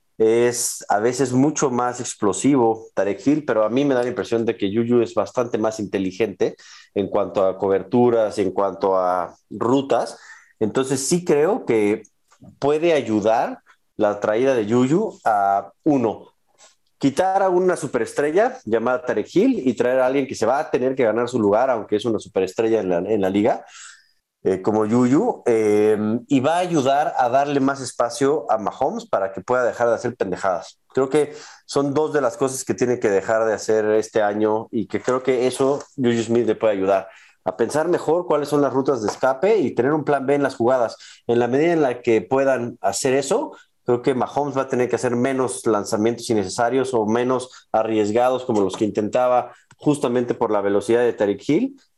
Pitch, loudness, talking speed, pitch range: 120 Hz, -20 LUFS, 195 wpm, 110-135 Hz